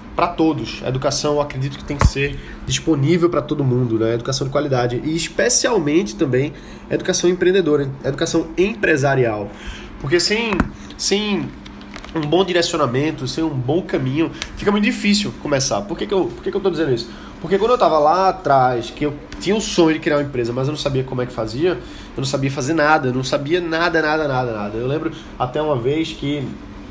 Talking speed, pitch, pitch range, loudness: 205 wpm, 150 Hz, 130-170 Hz, -19 LUFS